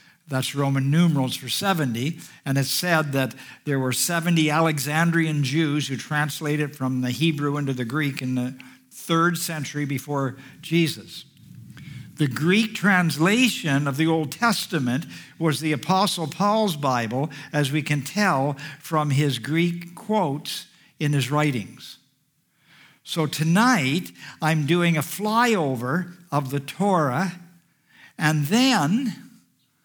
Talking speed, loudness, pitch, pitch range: 125 wpm, -23 LUFS, 155 Hz, 140-175 Hz